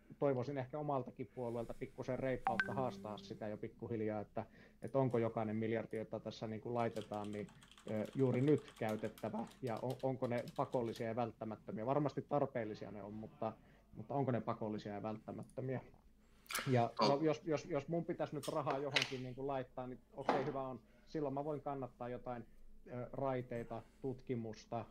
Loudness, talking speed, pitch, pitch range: -41 LUFS, 160 wpm, 125 Hz, 110-135 Hz